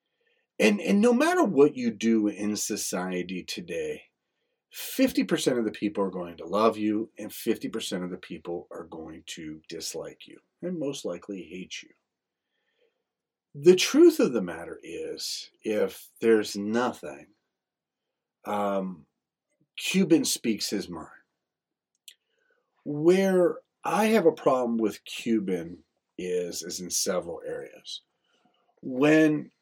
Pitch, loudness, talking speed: 145 Hz, -26 LUFS, 125 wpm